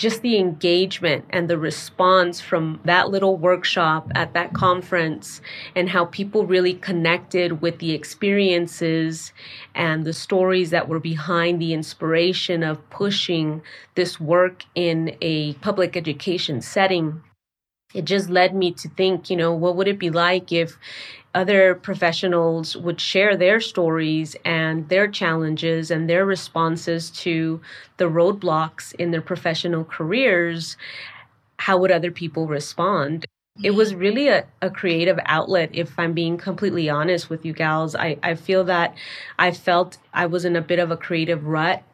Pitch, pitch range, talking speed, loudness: 175 Hz, 160-185 Hz, 150 wpm, -21 LUFS